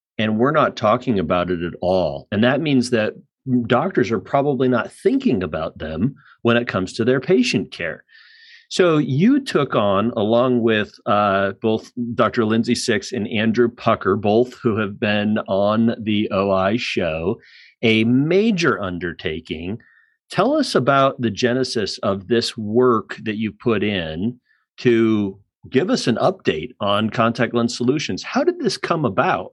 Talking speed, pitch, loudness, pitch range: 155 wpm, 120 Hz, -19 LUFS, 105-130 Hz